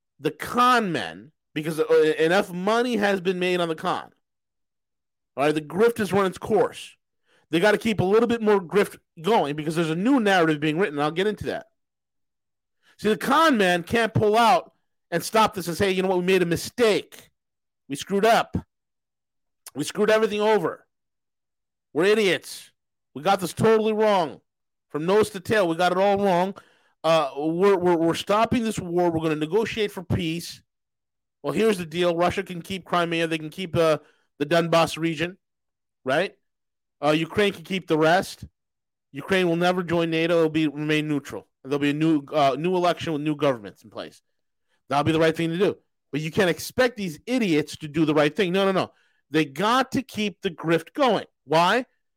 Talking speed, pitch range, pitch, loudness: 195 wpm, 155-205 Hz, 175 Hz, -23 LUFS